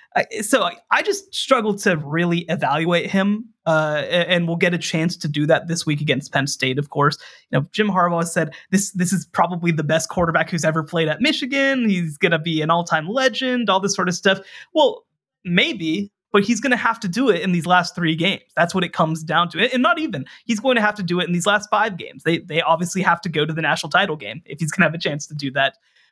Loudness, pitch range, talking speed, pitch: -19 LUFS, 160-205 Hz, 255 wpm, 175 Hz